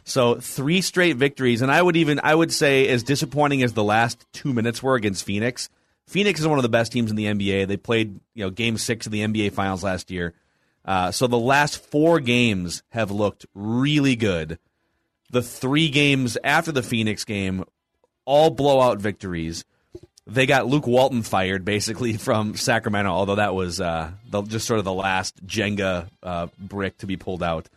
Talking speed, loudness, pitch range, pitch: 190 wpm, -22 LUFS, 100-135 Hz, 115 Hz